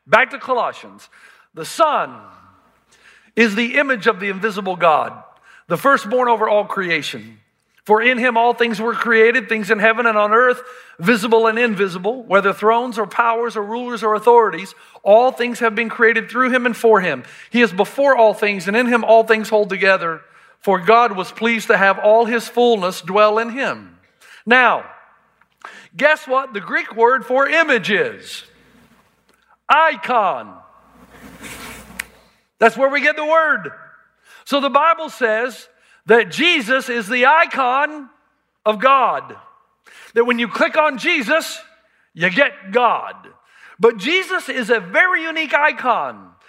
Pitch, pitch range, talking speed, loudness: 235 Hz, 220-270 Hz, 150 wpm, -16 LUFS